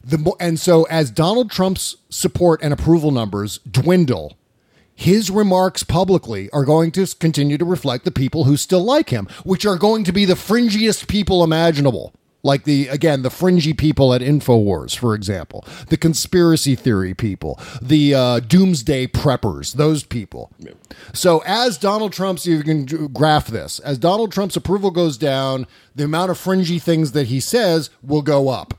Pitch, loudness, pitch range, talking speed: 155 Hz, -17 LUFS, 130-180 Hz, 165 wpm